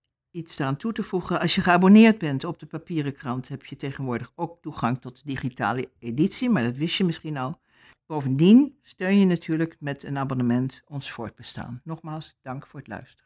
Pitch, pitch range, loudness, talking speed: 150 Hz, 130-170 Hz, -23 LUFS, 185 wpm